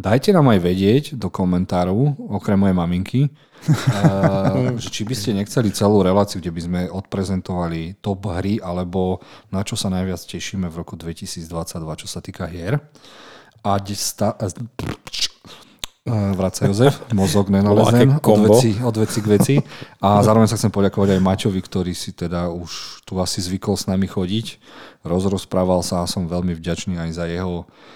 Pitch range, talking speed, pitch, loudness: 90-110 Hz, 150 wpm, 95 Hz, -19 LUFS